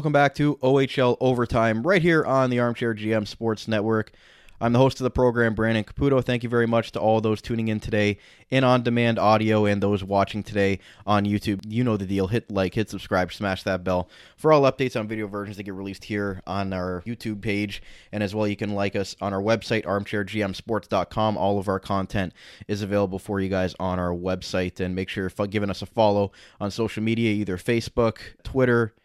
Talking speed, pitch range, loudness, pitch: 215 wpm, 100-115 Hz, -24 LUFS, 105 Hz